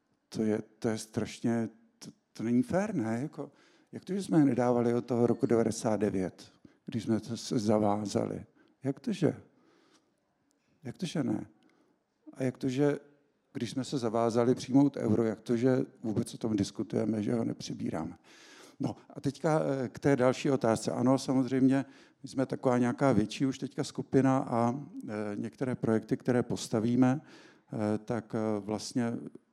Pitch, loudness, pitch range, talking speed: 125 Hz, -31 LUFS, 115-135 Hz, 155 wpm